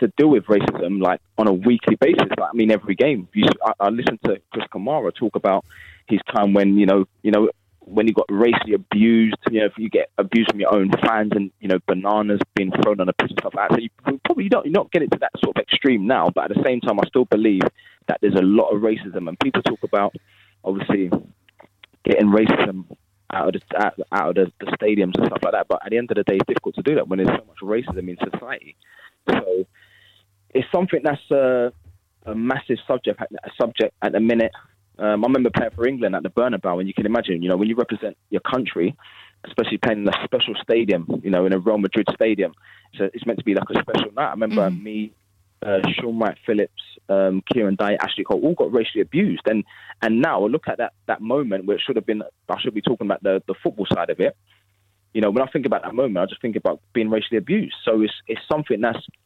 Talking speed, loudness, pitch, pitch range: 245 wpm, -20 LUFS, 105 Hz, 95-110 Hz